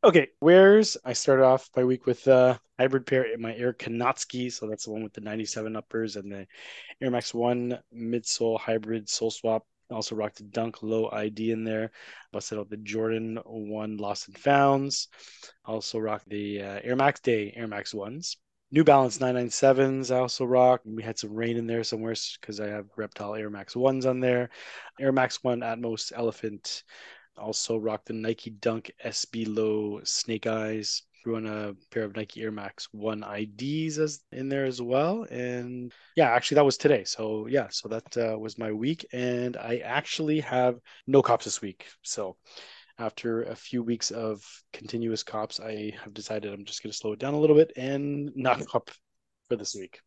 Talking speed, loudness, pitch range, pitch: 190 wpm, -27 LUFS, 110-125 Hz, 115 Hz